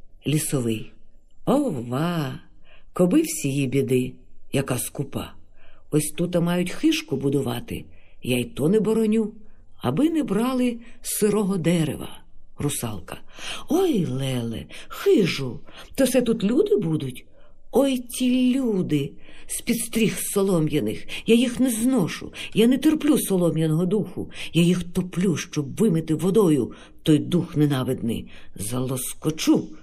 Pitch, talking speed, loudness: 170 Hz, 115 wpm, -23 LUFS